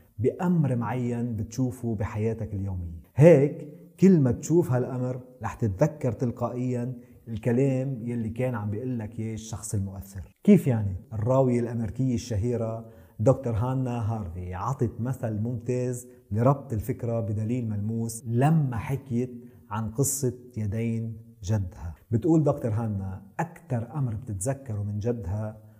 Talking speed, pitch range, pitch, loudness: 115 wpm, 110-130 Hz, 120 Hz, -27 LUFS